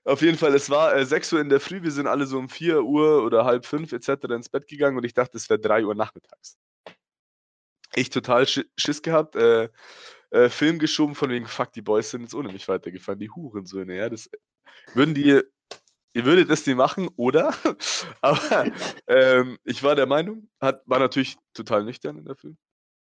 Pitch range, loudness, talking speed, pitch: 125-155 Hz, -22 LUFS, 205 wpm, 140 Hz